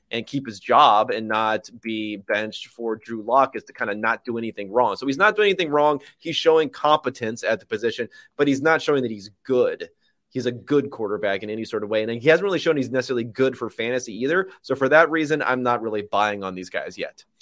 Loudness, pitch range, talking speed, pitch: -22 LUFS, 110-150 Hz, 240 wpm, 125 Hz